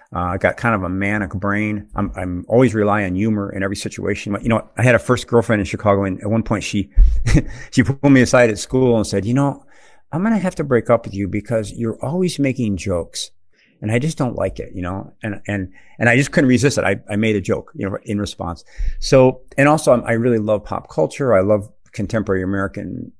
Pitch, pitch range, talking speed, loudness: 110 Hz, 100-125 Hz, 240 wpm, -18 LUFS